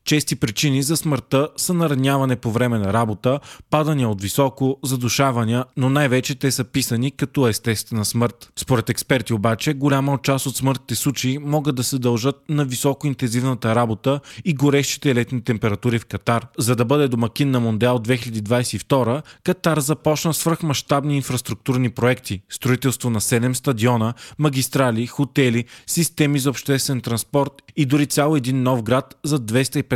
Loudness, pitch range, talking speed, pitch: -20 LUFS, 120-145 Hz, 150 wpm, 130 Hz